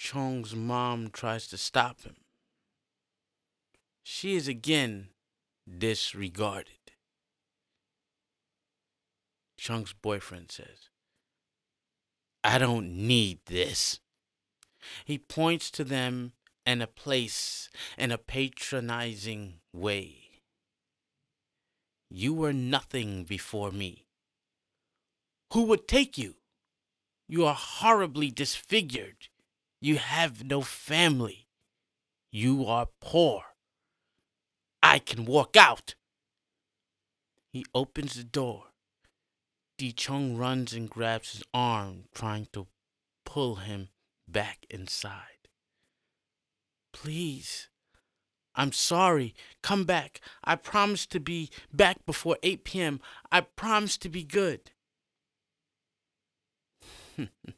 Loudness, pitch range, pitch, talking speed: -28 LUFS, 110-155 Hz, 125 Hz, 90 wpm